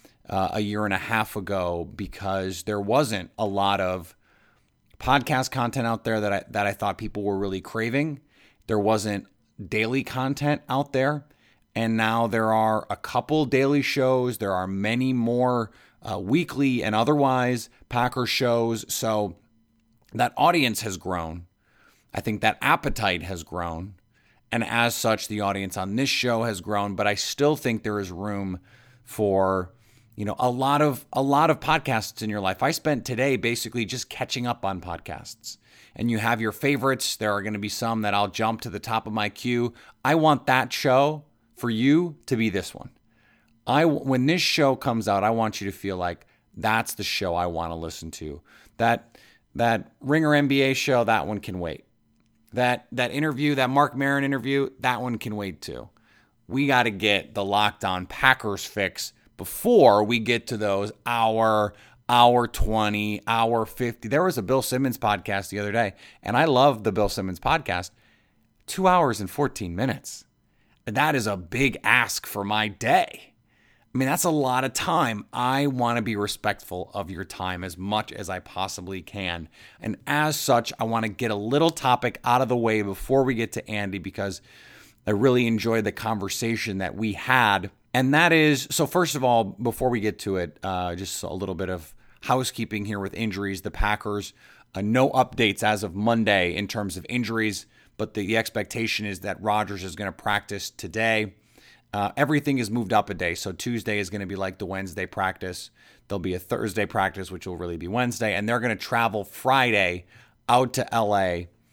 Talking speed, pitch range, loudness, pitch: 190 wpm, 100-125 Hz, -24 LUFS, 110 Hz